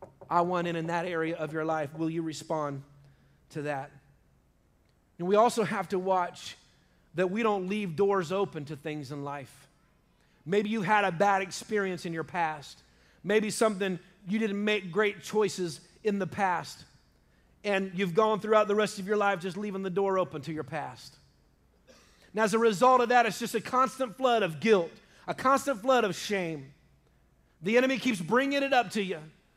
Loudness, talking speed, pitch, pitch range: -29 LUFS, 185 wpm, 190 Hz, 160-215 Hz